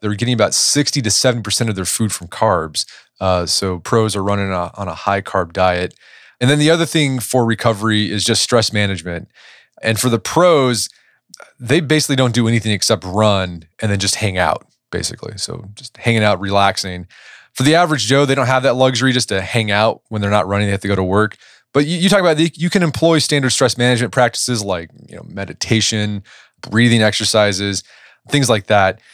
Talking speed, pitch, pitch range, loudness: 210 wpm, 110 Hz, 100-125 Hz, -16 LUFS